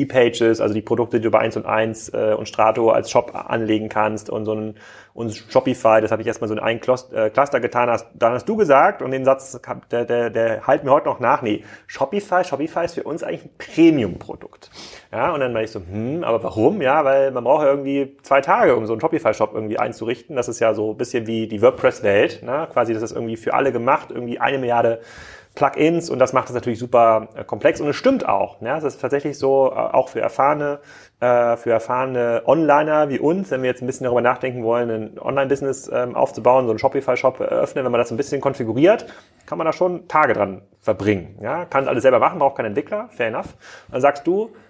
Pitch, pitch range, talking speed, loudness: 120 Hz, 110-135 Hz, 225 wpm, -19 LUFS